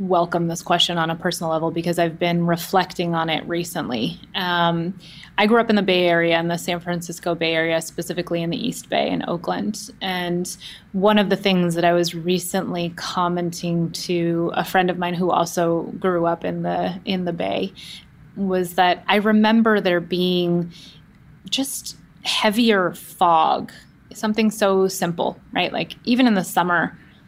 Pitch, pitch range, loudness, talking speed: 175 Hz, 170-190 Hz, -21 LUFS, 170 wpm